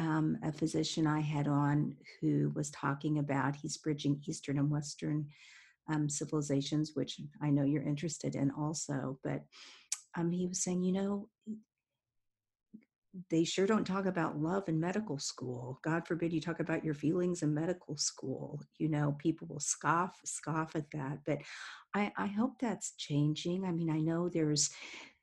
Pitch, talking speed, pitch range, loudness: 155 Hz, 165 wpm, 145-170 Hz, -35 LUFS